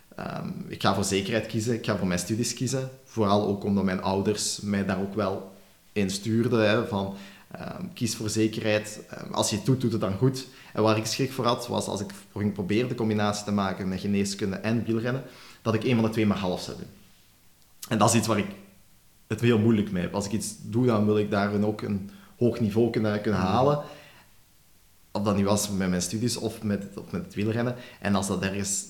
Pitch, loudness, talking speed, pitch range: 105 Hz, -27 LUFS, 225 wpm, 100-115 Hz